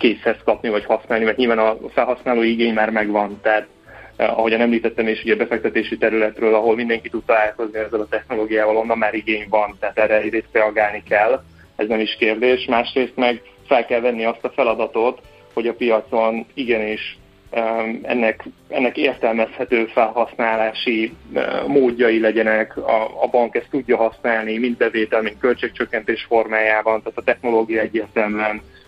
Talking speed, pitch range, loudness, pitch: 150 wpm, 110-115 Hz, -19 LUFS, 110 Hz